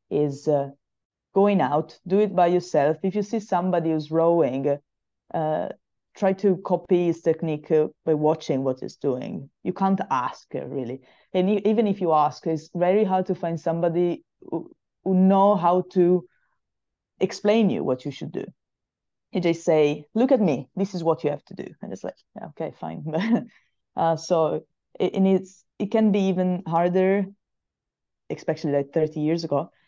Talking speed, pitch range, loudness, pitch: 170 wpm, 155-195 Hz, -24 LUFS, 175 Hz